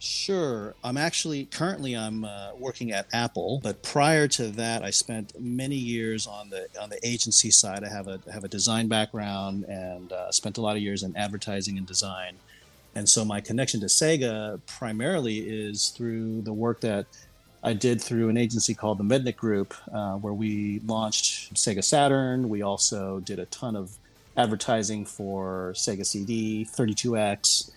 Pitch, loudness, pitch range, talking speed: 110 Hz, -26 LUFS, 100-115 Hz, 170 wpm